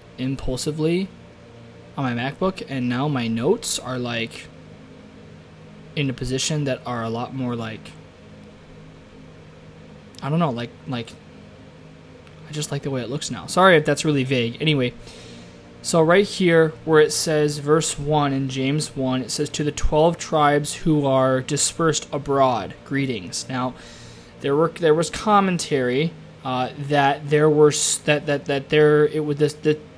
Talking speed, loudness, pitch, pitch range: 155 wpm, -21 LUFS, 145 Hz, 130-155 Hz